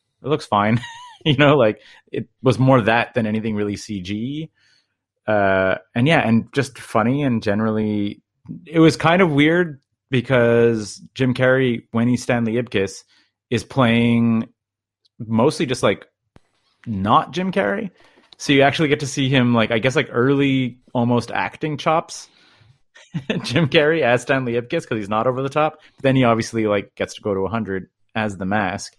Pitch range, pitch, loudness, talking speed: 110-140 Hz, 120 Hz, -19 LUFS, 170 wpm